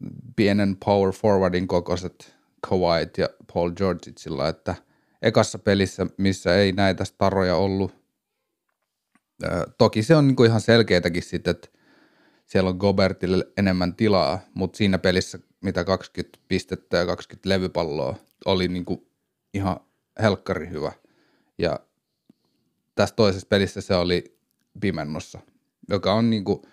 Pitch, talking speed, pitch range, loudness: 95 Hz, 115 wpm, 90-100 Hz, -23 LUFS